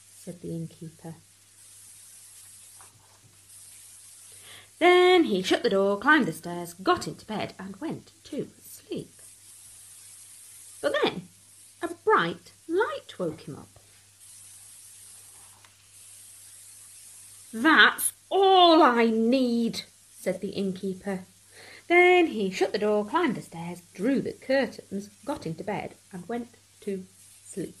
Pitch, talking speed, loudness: 165 Hz, 110 wpm, -25 LUFS